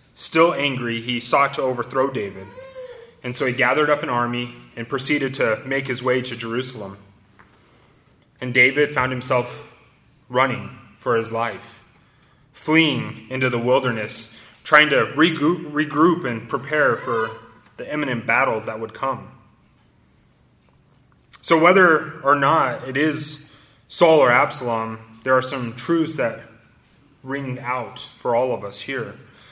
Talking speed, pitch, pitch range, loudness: 140 wpm, 130 Hz, 115-150 Hz, -20 LUFS